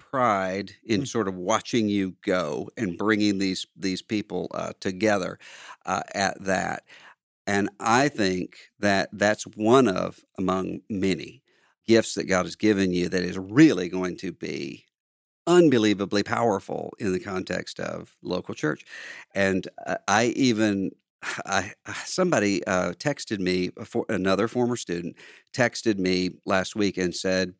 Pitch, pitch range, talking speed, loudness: 95 Hz, 90-110 Hz, 135 wpm, -25 LUFS